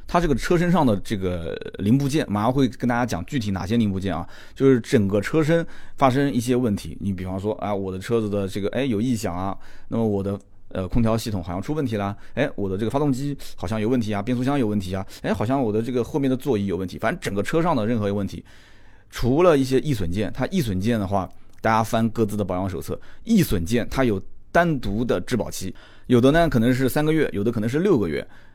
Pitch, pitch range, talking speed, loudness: 110 Hz, 100-130 Hz, 360 characters per minute, -23 LUFS